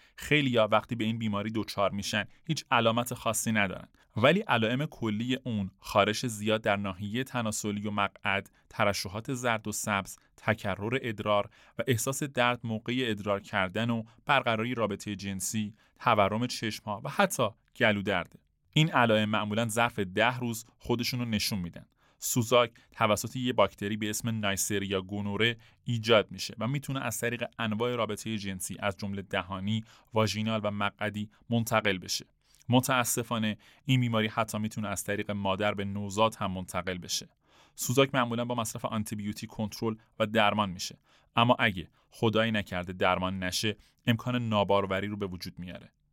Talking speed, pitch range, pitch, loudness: 150 wpm, 100-120 Hz, 110 Hz, -30 LUFS